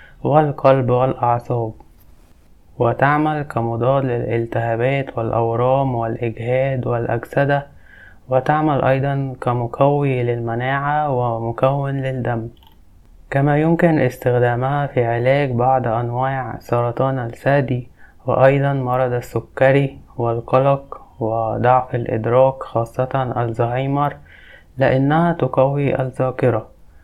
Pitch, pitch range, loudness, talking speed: 130 Hz, 115-135 Hz, -18 LUFS, 75 wpm